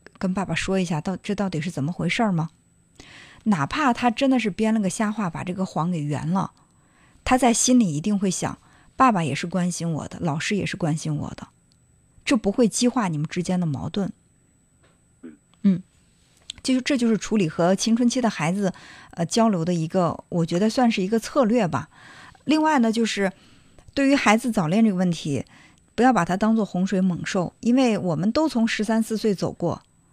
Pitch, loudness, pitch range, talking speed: 195 Hz, -23 LUFS, 175-230 Hz, 275 characters per minute